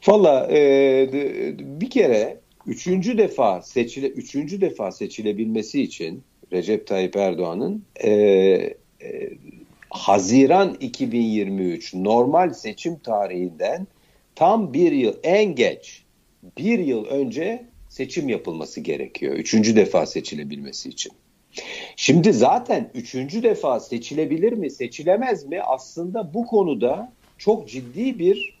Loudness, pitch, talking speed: -21 LUFS, 150 Hz, 105 wpm